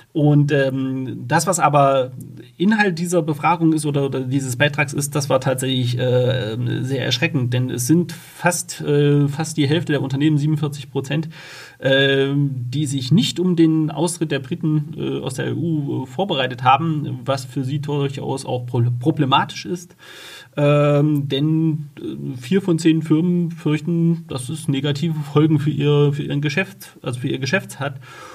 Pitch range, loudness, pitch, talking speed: 135-160 Hz, -19 LUFS, 145 Hz, 160 wpm